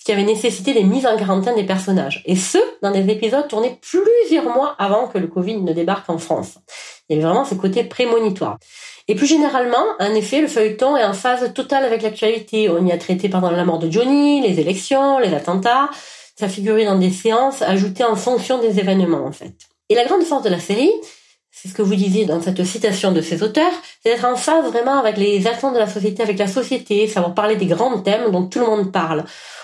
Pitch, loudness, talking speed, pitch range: 215 Hz, -17 LUFS, 230 wpm, 190-250 Hz